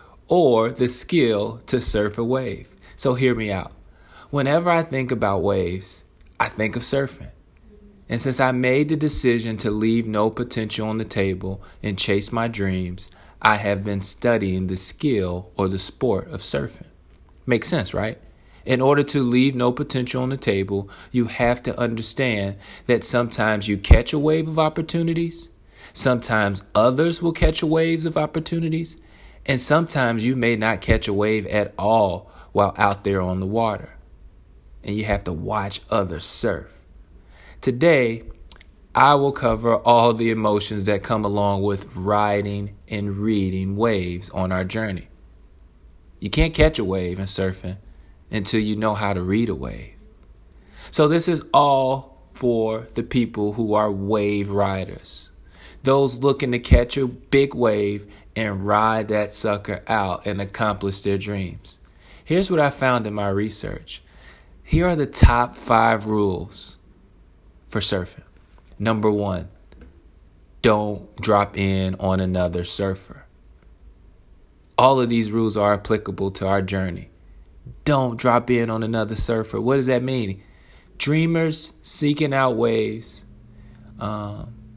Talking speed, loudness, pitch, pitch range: 150 wpm, -21 LUFS, 105 Hz, 95-125 Hz